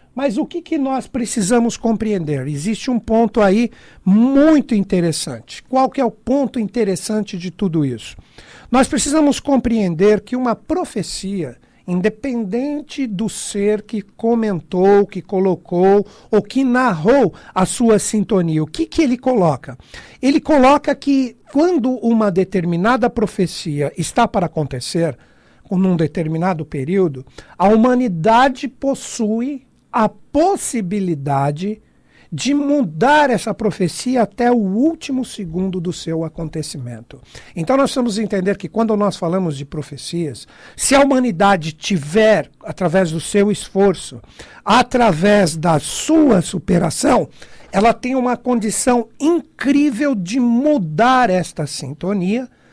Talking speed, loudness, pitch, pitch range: 120 wpm, -17 LUFS, 210 Hz, 180-255 Hz